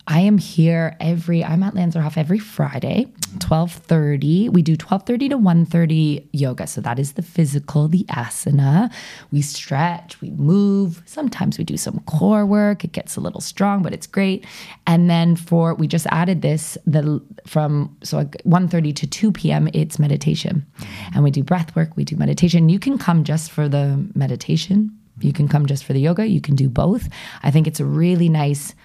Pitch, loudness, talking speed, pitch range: 165 Hz, -19 LUFS, 185 wpm, 150-185 Hz